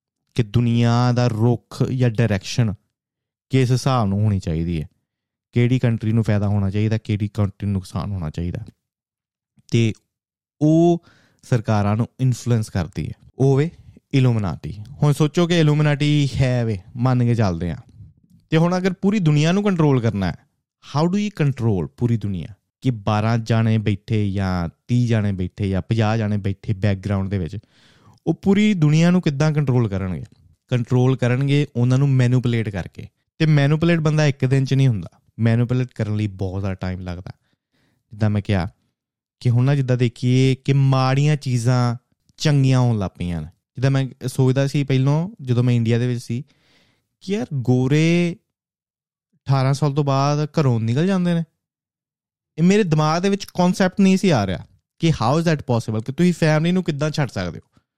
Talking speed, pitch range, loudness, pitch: 165 wpm, 105-145 Hz, -20 LUFS, 125 Hz